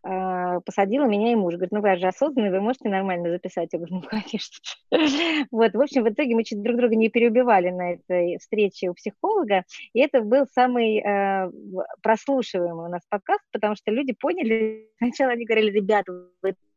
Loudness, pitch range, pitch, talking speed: -23 LUFS, 185-245 Hz, 215 Hz, 180 wpm